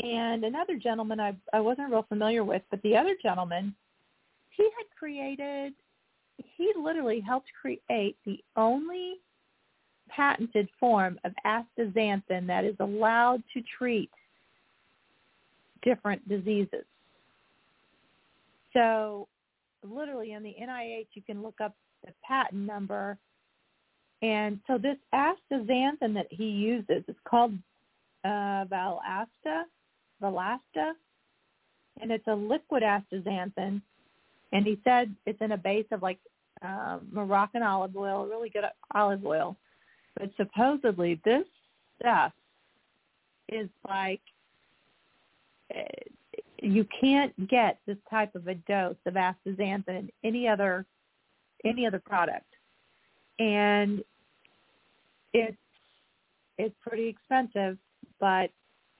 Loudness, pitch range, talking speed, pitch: -30 LUFS, 200-245 Hz, 110 wpm, 215 Hz